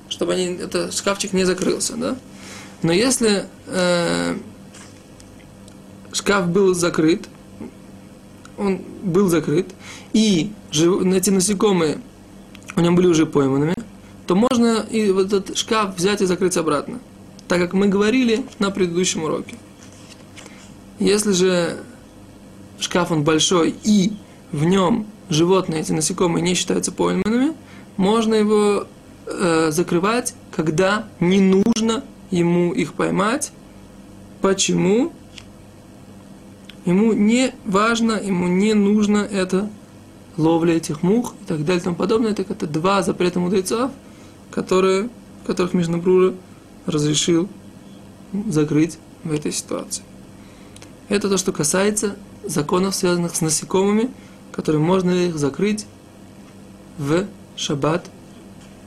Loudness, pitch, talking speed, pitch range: -19 LUFS, 185 Hz, 110 wpm, 170-205 Hz